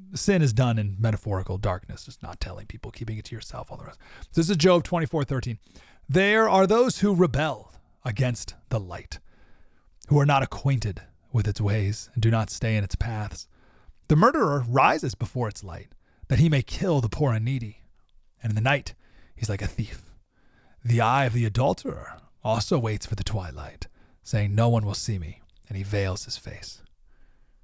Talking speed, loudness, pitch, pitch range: 195 wpm, -25 LUFS, 115 Hz, 105-135 Hz